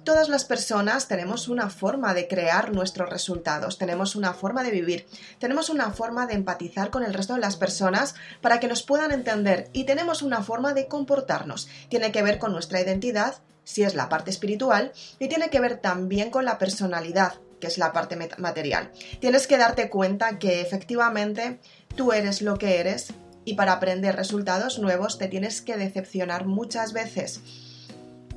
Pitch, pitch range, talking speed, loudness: 205 Hz, 185-235 Hz, 175 wpm, -25 LUFS